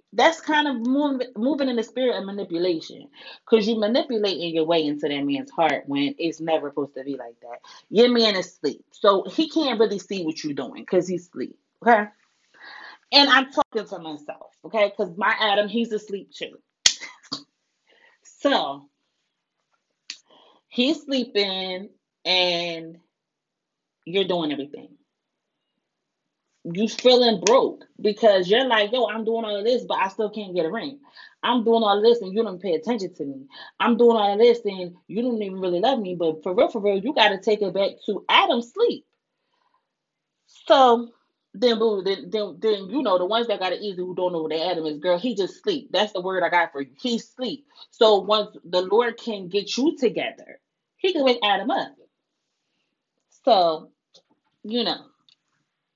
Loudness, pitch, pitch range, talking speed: -22 LUFS, 215 Hz, 180-245 Hz, 175 wpm